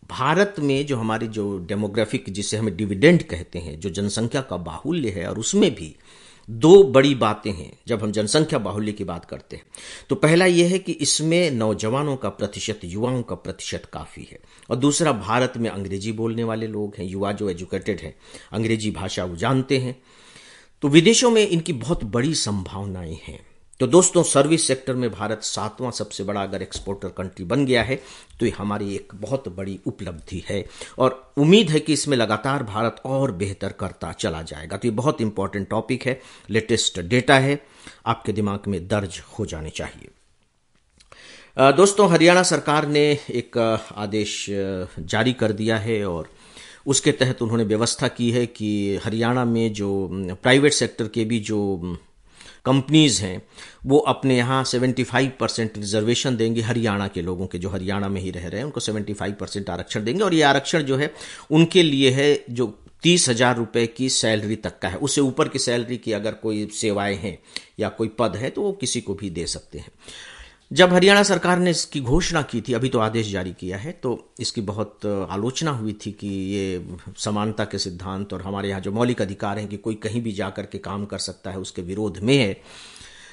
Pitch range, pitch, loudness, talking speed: 100-130 Hz, 110 Hz, -21 LUFS, 185 wpm